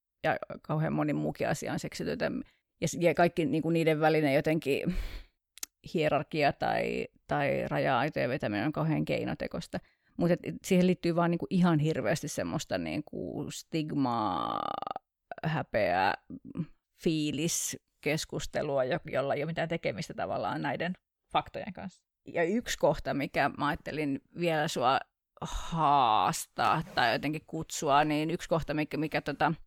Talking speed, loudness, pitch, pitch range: 125 wpm, -31 LUFS, 155 Hz, 150-170 Hz